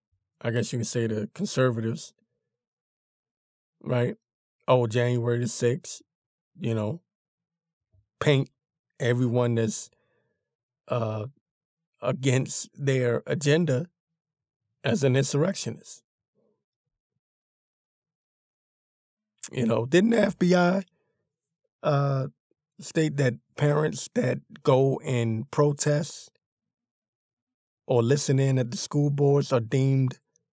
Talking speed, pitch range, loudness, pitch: 90 wpm, 120-155 Hz, -26 LUFS, 135 Hz